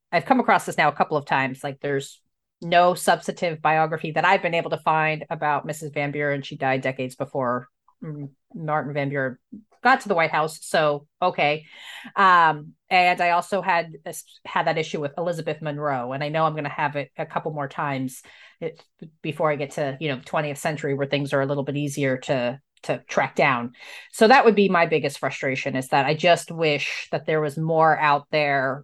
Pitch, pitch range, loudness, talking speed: 150 Hz, 140-165 Hz, -22 LUFS, 205 wpm